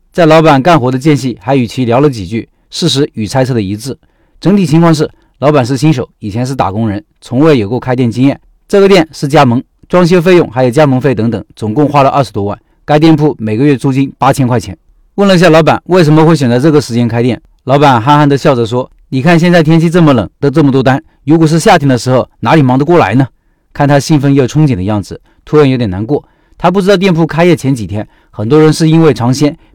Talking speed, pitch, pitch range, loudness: 350 characters per minute, 140 Hz, 125-160 Hz, -9 LUFS